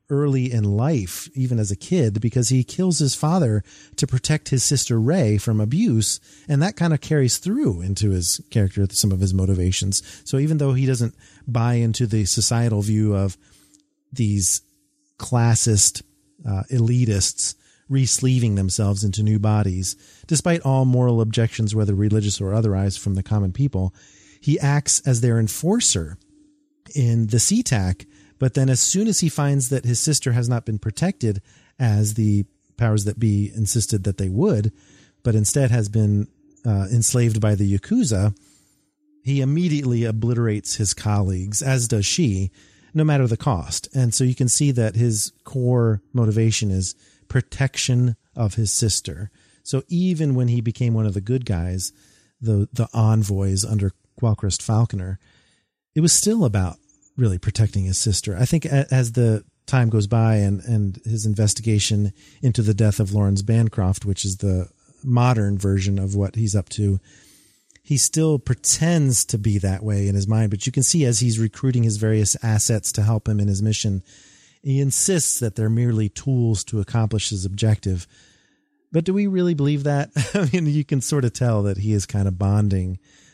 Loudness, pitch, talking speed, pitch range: -20 LUFS, 110 Hz, 170 wpm, 100-130 Hz